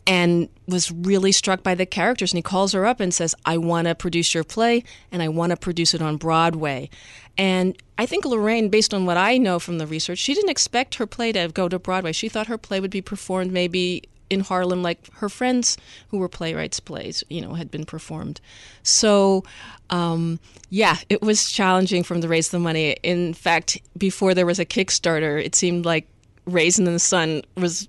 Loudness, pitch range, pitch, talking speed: -21 LUFS, 170-195 Hz, 180 Hz, 210 wpm